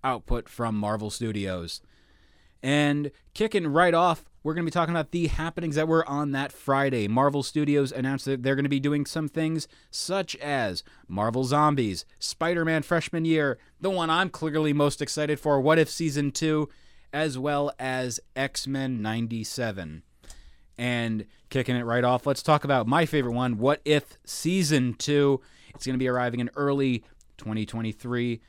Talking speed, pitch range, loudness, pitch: 170 wpm, 120-155 Hz, -26 LUFS, 140 Hz